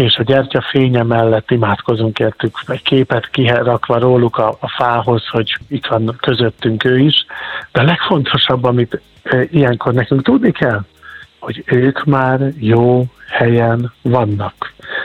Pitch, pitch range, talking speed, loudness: 125 Hz, 115-135 Hz, 130 wpm, -14 LUFS